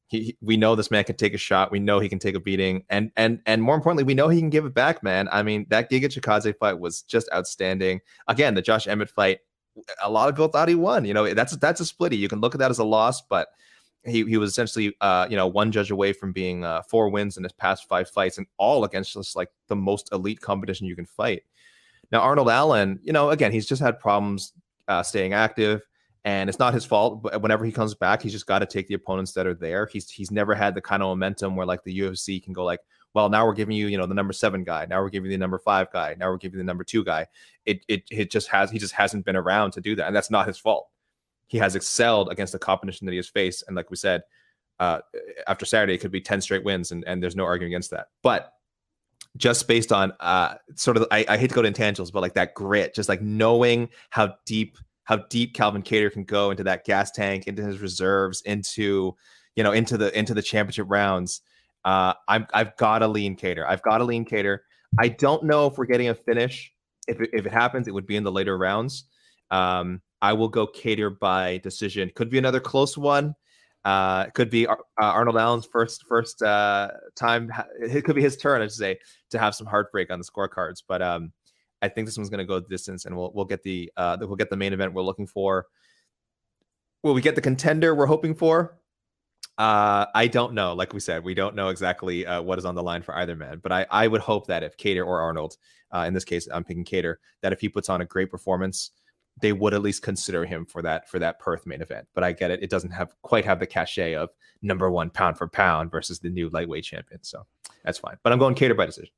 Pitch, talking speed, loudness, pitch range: 100 Hz, 255 wpm, -24 LUFS, 95-115 Hz